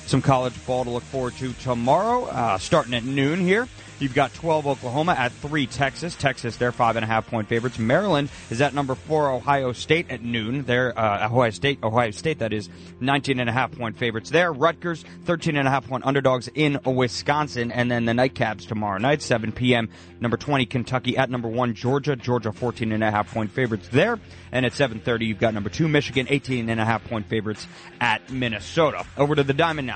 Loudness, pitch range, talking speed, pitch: -23 LUFS, 115-140 Hz, 200 wpm, 125 Hz